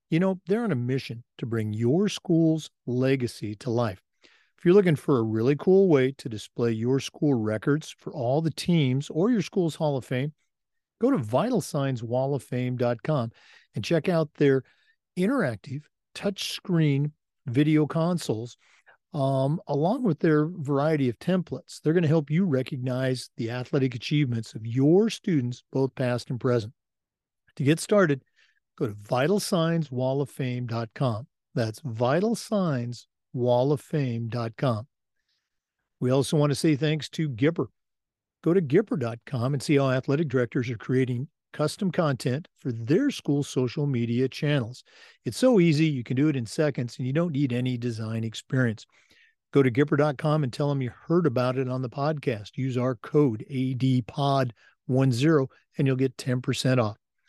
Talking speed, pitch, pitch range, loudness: 150 wpm, 135 Hz, 125-155 Hz, -26 LUFS